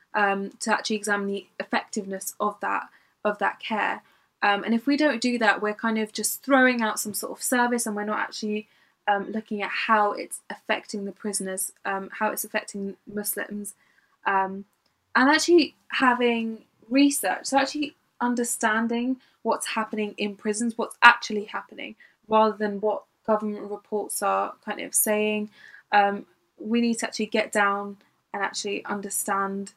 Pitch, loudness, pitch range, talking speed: 215 Hz, -25 LUFS, 205-230 Hz, 160 wpm